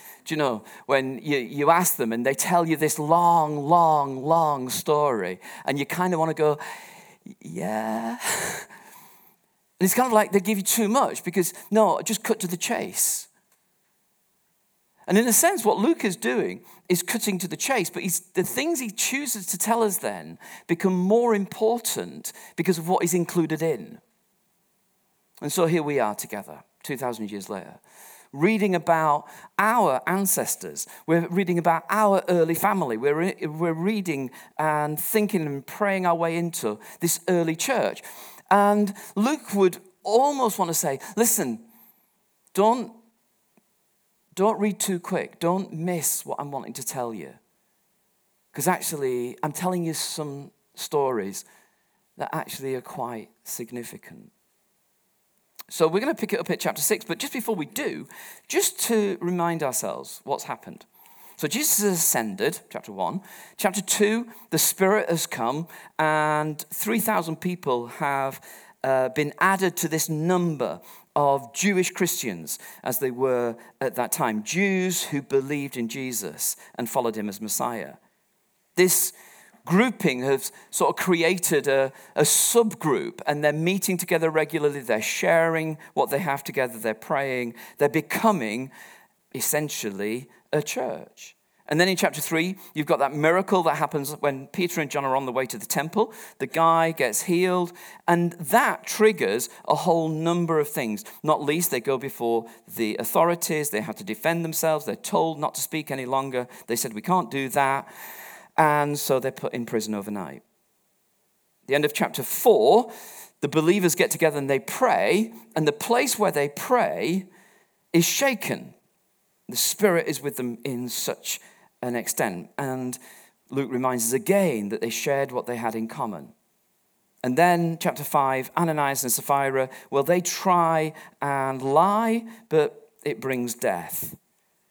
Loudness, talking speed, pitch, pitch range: -24 LUFS, 155 wpm, 165 Hz, 140-195 Hz